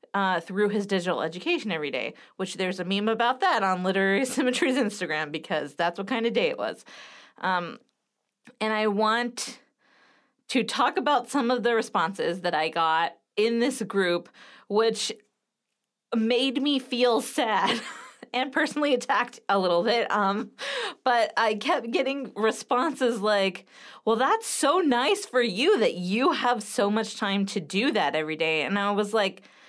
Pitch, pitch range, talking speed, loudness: 220 Hz, 195-255 Hz, 165 wpm, -26 LUFS